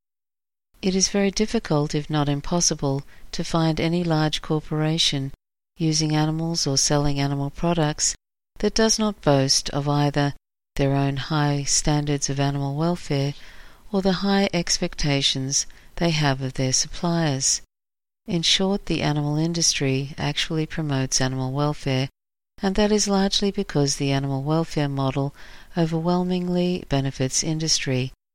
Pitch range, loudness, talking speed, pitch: 140-175 Hz, -22 LUFS, 130 wpm, 150 Hz